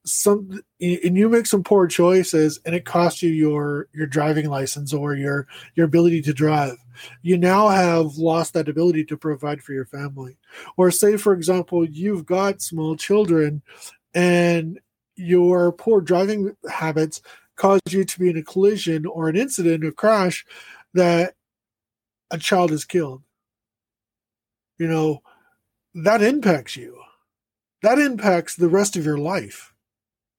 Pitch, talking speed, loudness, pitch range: 165 Hz, 145 wpm, -20 LUFS, 150-185 Hz